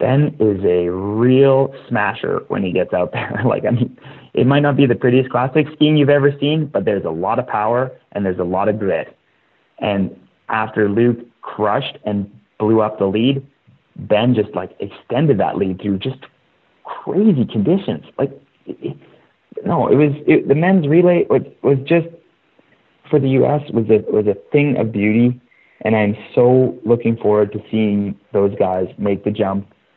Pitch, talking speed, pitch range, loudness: 120 Hz, 180 wpm, 105-140 Hz, -17 LUFS